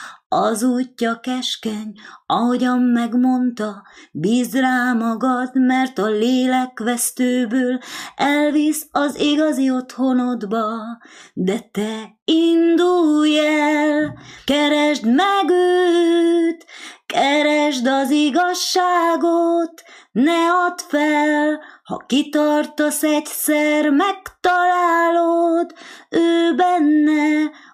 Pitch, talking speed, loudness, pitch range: 295 Hz, 75 wpm, -18 LUFS, 250-335 Hz